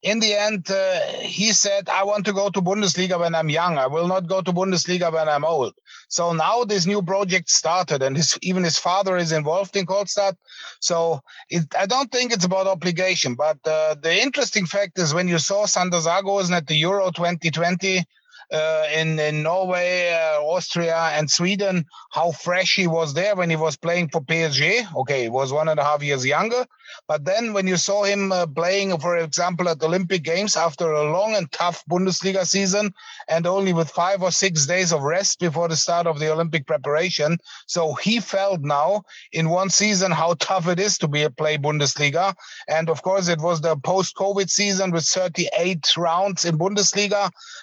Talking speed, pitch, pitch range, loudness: 195 wpm, 175 Hz, 160-195 Hz, -21 LUFS